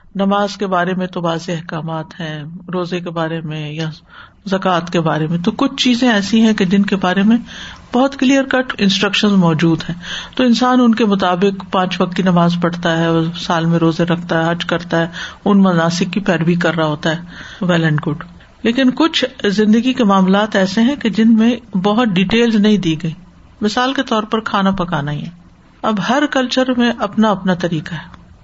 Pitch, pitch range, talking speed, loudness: 190 Hz, 170-225 Hz, 200 wpm, -15 LUFS